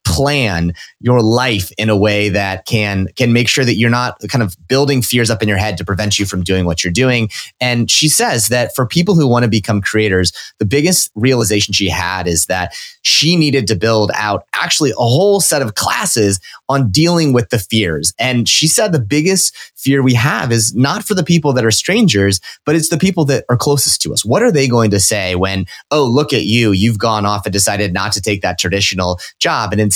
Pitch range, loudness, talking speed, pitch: 100-135 Hz, -13 LUFS, 225 wpm, 115 Hz